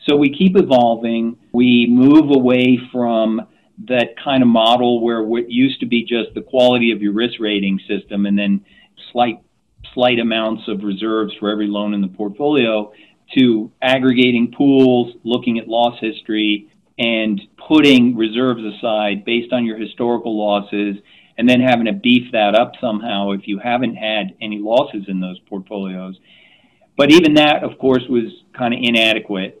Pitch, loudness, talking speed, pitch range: 115 Hz, -16 LUFS, 160 wpm, 105-125 Hz